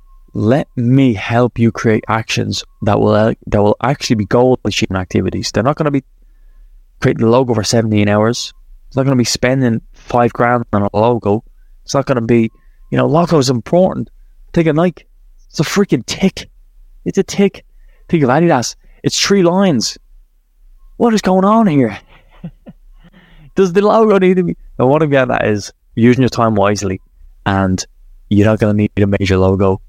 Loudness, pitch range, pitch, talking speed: -14 LUFS, 105-155 Hz, 120 Hz, 190 wpm